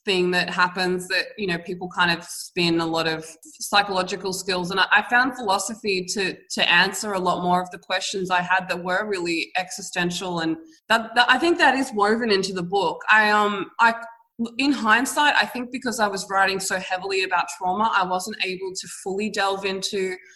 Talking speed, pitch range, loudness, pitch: 200 wpm, 180-215 Hz, -22 LUFS, 190 Hz